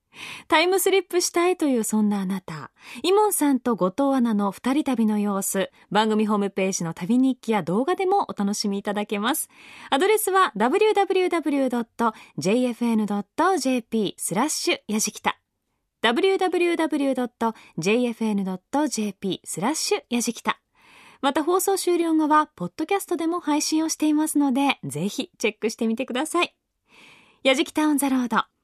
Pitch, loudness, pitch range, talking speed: 255 Hz, -23 LUFS, 215-320 Hz, 285 characters per minute